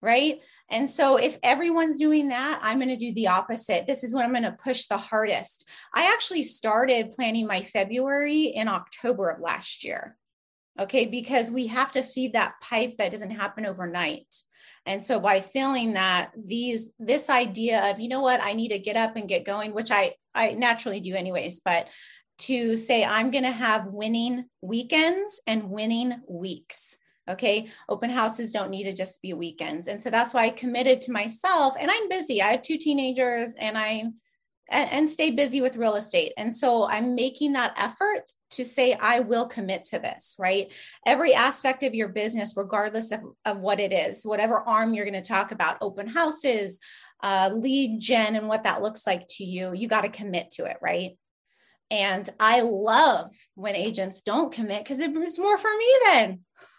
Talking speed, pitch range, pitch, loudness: 190 wpm, 205-260 Hz, 230 Hz, -25 LUFS